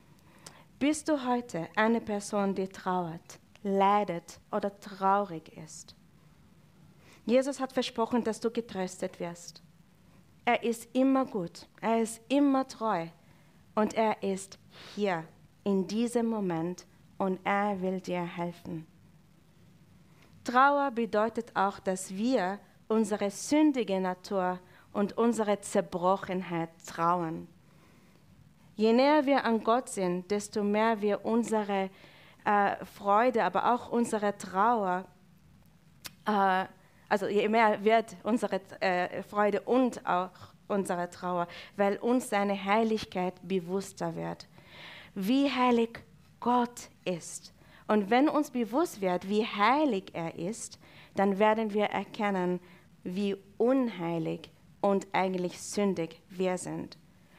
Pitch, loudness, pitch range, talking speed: 200 Hz, -30 LUFS, 180-225 Hz, 115 wpm